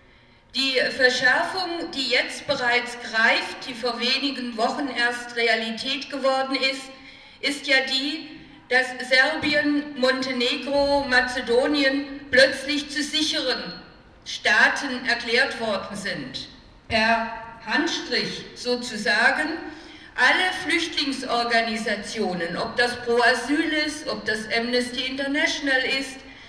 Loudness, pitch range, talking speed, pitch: -22 LUFS, 235-280 Hz, 95 wpm, 260 Hz